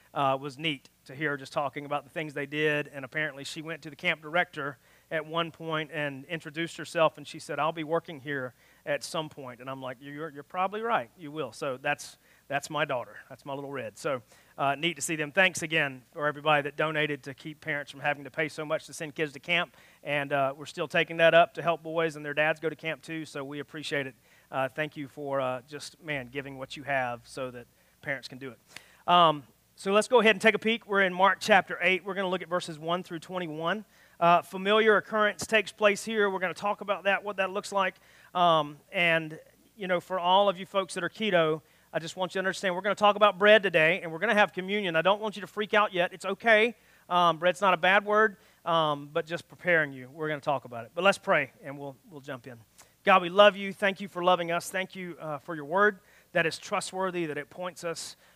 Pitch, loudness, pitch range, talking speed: 165 Hz, -28 LUFS, 145-185 Hz, 255 wpm